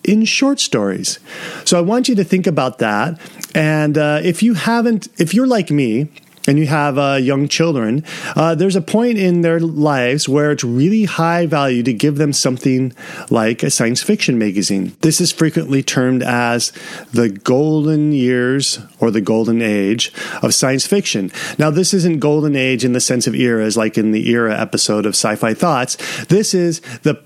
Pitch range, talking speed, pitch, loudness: 125-175 Hz, 185 wpm, 150 Hz, -15 LUFS